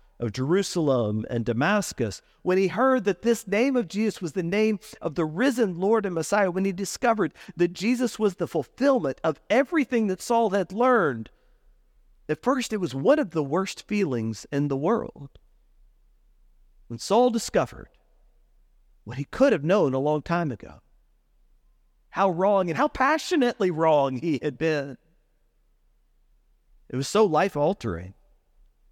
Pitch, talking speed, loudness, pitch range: 185 Hz, 150 wpm, -25 LUFS, 145-225 Hz